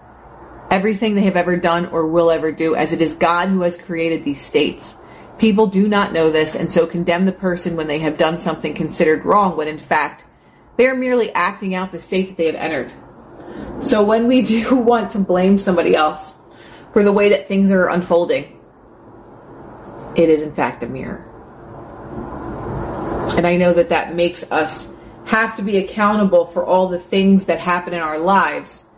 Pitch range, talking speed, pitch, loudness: 165-200 Hz, 190 wpm, 175 Hz, -17 LUFS